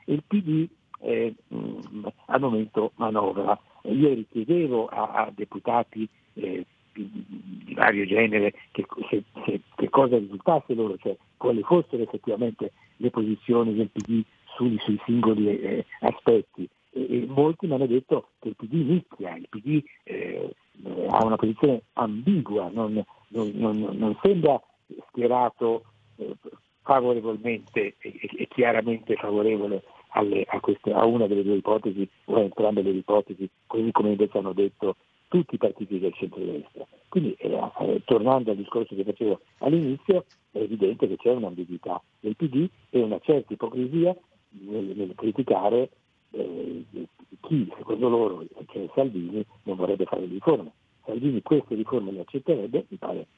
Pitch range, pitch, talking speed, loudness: 105-130 Hz, 115 Hz, 145 wpm, -26 LUFS